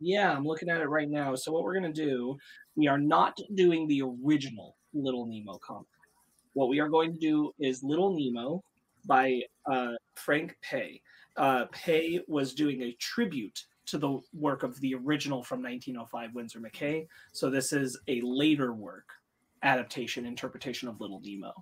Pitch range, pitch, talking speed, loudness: 125-160 Hz, 140 Hz, 170 wpm, -31 LUFS